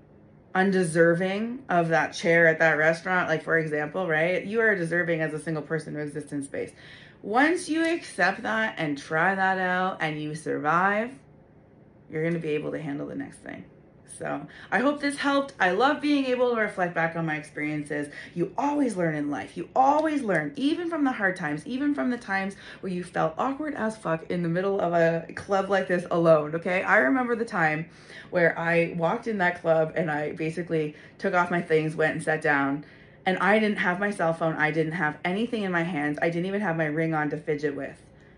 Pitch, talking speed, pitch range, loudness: 170 Hz, 210 wpm, 155-205 Hz, -26 LUFS